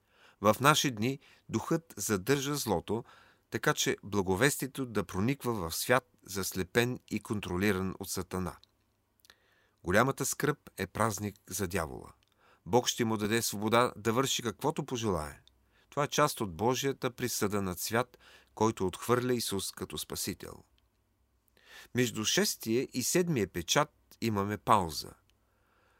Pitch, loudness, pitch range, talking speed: 110 Hz, -32 LUFS, 100-130 Hz, 120 wpm